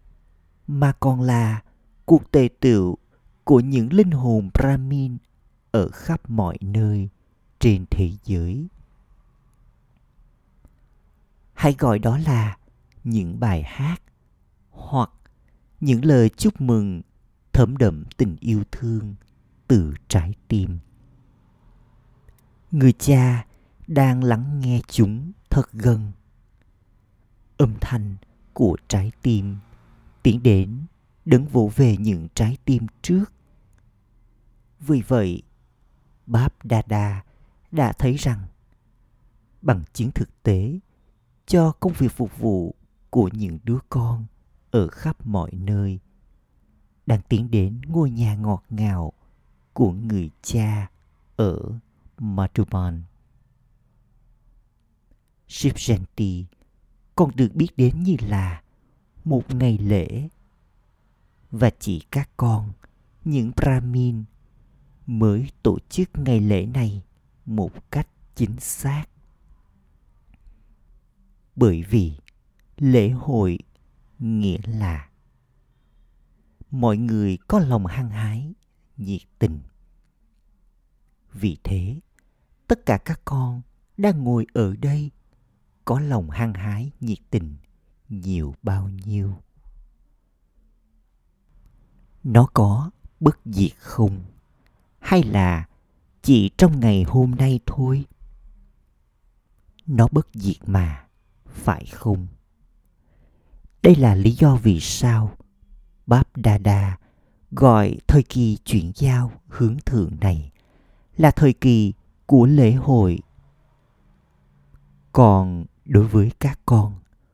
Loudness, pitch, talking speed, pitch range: -21 LUFS, 110 Hz, 100 wpm, 95-125 Hz